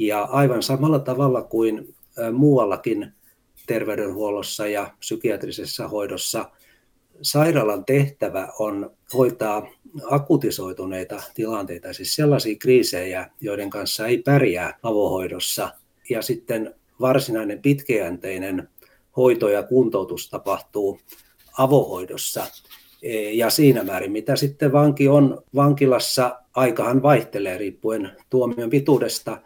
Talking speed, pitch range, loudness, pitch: 95 wpm, 105-140 Hz, -21 LUFS, 125 Hz